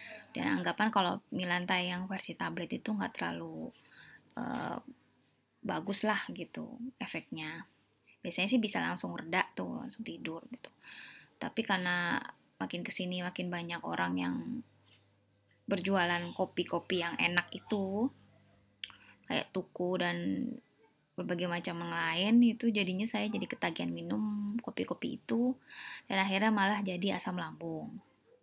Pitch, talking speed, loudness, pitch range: 185 Hz, 120 wpm, -34 LUFS, 170-215 Hz